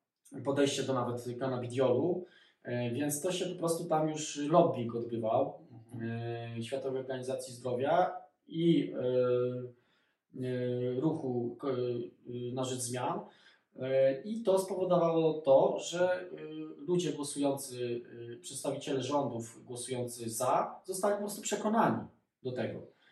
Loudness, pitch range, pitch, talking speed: -33 LUFS, 125-165 Hz, 135 Hz, 110 wpm